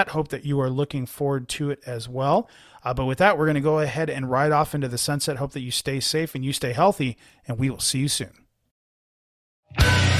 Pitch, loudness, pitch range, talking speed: 140 Hz, -24 LUFS, 130-150 Hz, 235 wpm